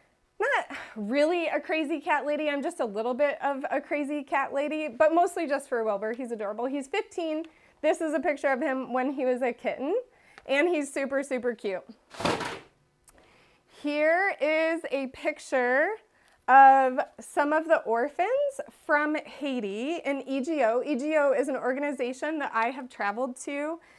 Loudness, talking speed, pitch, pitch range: -27 LUFS, 160 wpm, 285 Hz, 260-315 Hz